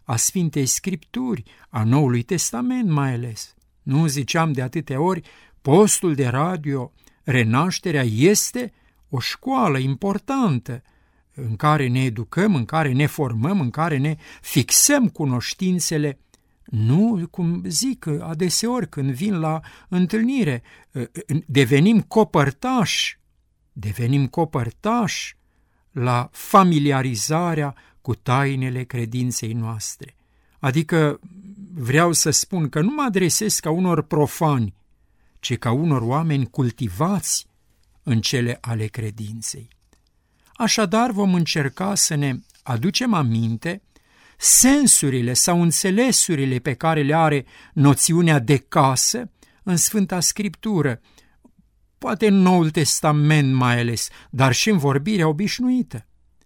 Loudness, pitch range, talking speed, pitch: -20 LUFS, 125-185 Hz, 110 wpm, 150 Hz